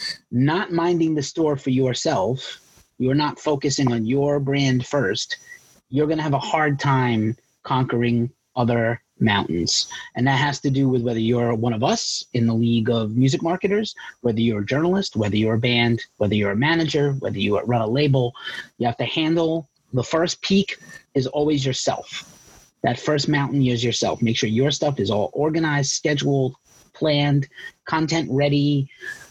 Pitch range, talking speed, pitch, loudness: 120-150 Hz, 170 wpm, 135 Hz, -21 LUFS